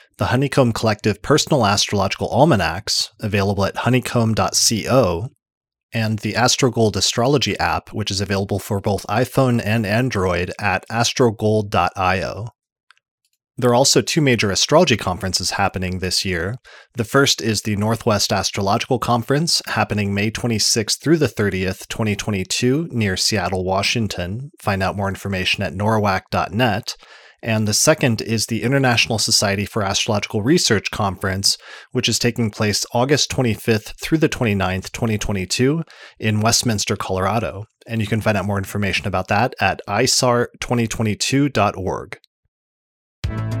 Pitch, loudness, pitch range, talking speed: 110 Hz, -18 LUFS, 100-120 Hz, 125 wpm